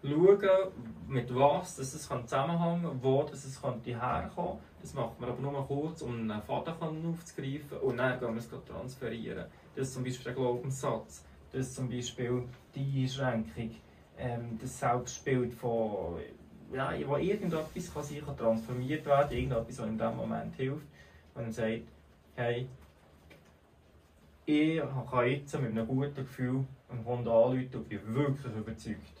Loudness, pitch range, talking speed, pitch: -34 LUFS, 115-140 Hz, 140 wpm, 125 Hz